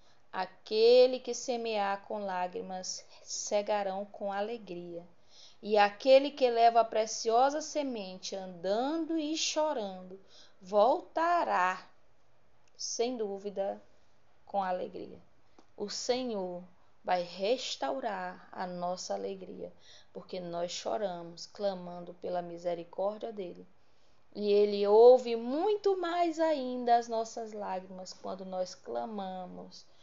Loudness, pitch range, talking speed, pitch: -31 LUFS, 185-245 Hz, 100 wpm, 205 Hz